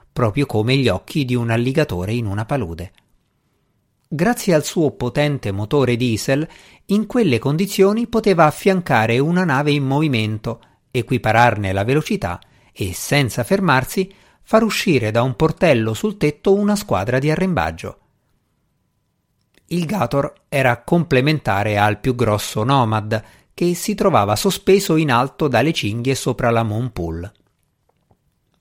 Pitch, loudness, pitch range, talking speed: 135 Hz, -18 LUFS, 115-170 Hz, 130 wpm